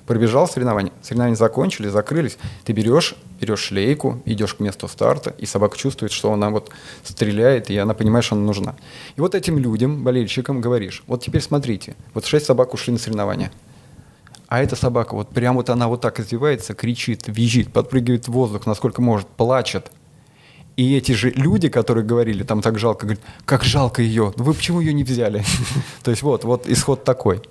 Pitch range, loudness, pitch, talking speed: 110-130 Hz, -19 LUFS, 120 Hz, 185 wpm